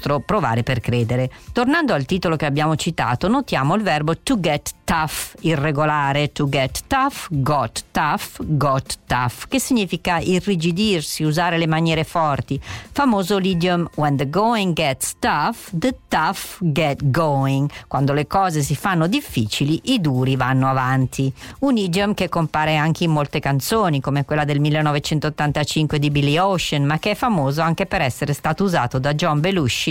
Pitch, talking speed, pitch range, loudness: 155 Hz, 155 wpm, 140-180 Hz, -20 LUFS